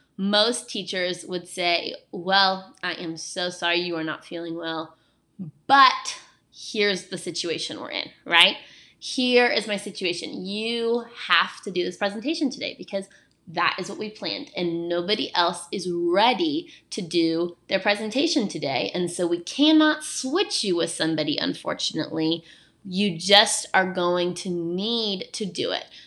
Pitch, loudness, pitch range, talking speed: 190 Hz, -24 LUFS, 175-225 Hz, 150 wpm